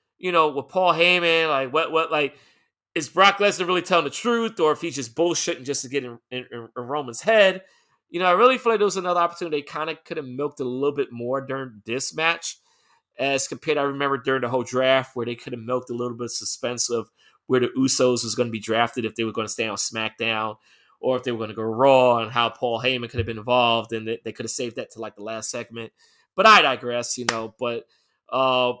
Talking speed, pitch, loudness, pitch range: 255 wpm, 130 Hz, -22 LUFS, 120-155 Hz